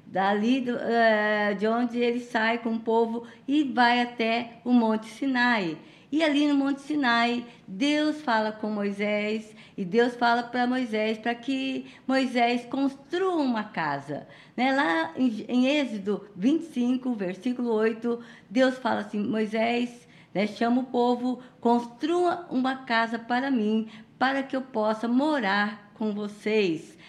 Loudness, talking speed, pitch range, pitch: -26 LUFS, 140 wpm, 215-255 Hz, 235 Hz